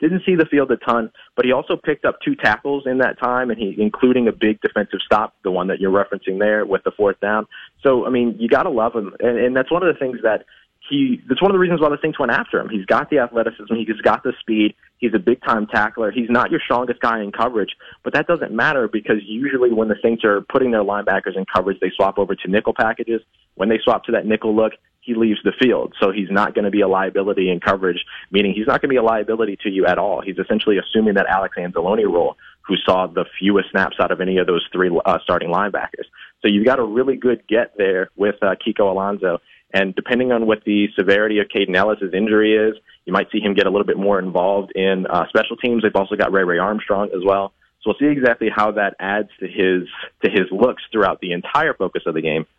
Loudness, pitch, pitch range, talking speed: -18 LUFS, 110 Hz, 100-125 Hz, 250 wpm